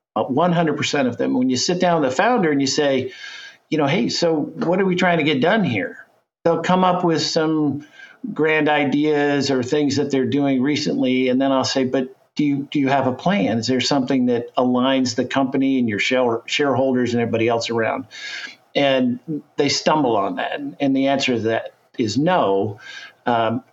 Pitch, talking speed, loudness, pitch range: 140 Hz, 200 wpm, -19 LUFS, 130-155 Hz